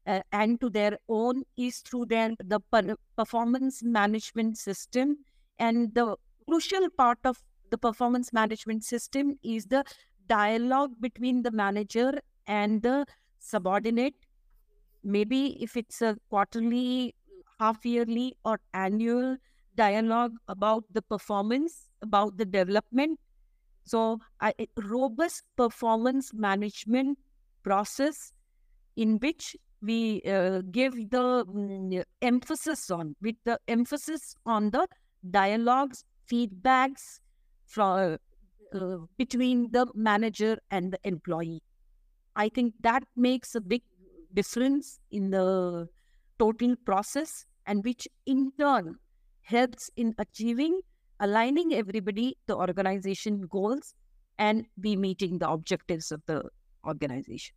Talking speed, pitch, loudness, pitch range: 110 wpm, 225 Hz, -29 LUFS, 205-255 Hz